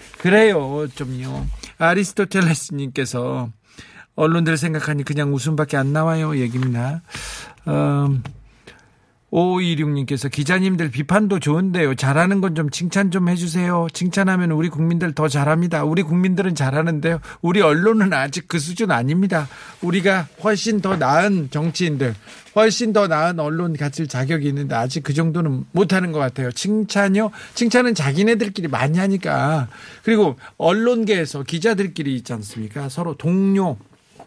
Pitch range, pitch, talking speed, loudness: 140-190 Hz, 165 Hz, 325 characters per minute, -19 LUFS